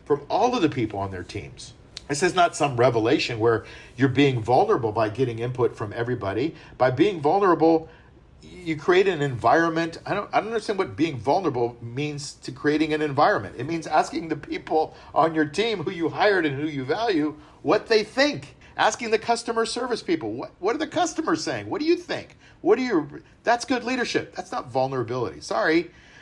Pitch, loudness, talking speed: 155 Hz, -24 LUFS, 195 wpm